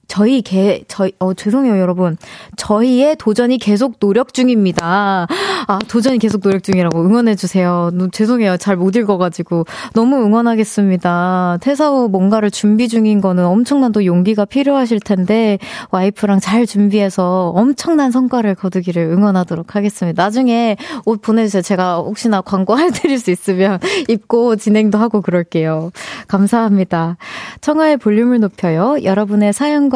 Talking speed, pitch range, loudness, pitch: 350 characters per minute, 185-235 Hz, -14 LUFS, 205 Hz